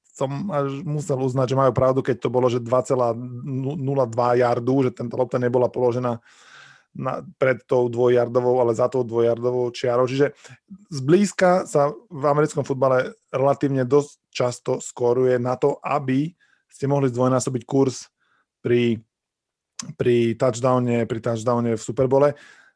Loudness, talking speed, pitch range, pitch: -22 LUFS, 135 wpm, 125-140 Hz, 130 Hz